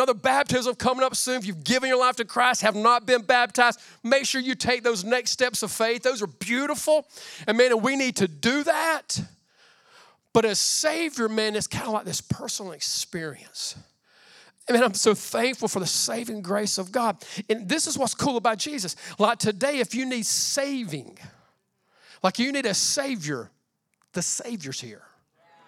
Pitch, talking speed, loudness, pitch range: 235 Hz, 190 wpm, -24 LUFS, 205-255 Hz